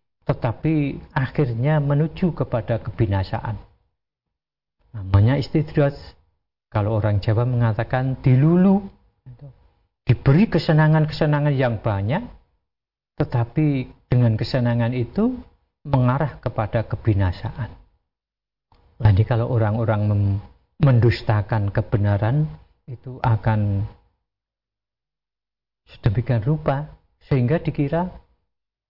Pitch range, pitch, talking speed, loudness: 110-145 Hz, 120 Hz, 75 wpm, -21 LUFS